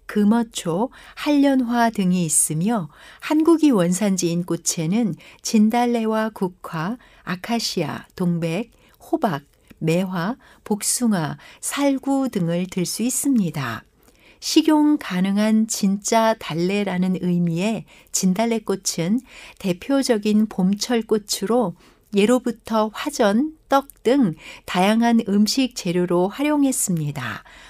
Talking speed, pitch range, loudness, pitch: 215 characters per minute, 180-240 Hz, -21 LUFS, 215 Hz